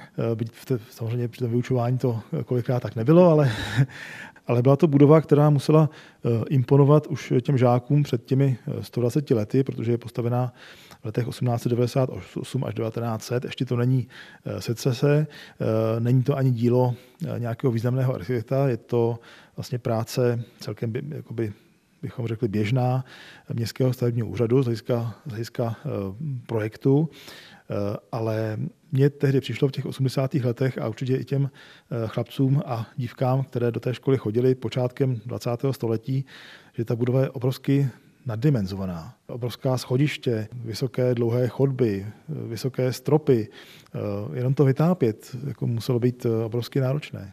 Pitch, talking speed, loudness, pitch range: 125 Hz, 135 wpm, -24 LUFS, 115-135 Hz